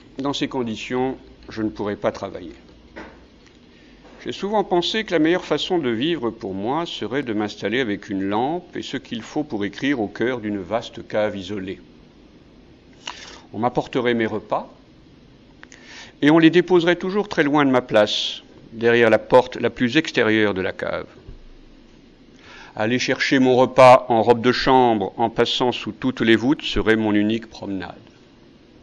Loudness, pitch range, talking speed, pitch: -20 LUFS, 105-140 Hz, 160 wpm, 120 Hz